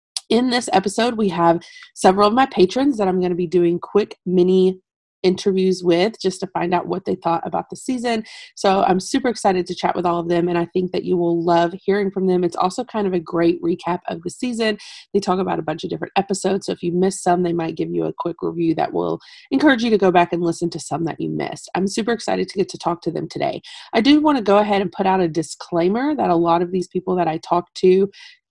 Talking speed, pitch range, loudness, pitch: 260 wpm, 175-205 Hz, -19 LUFS, 185 Hz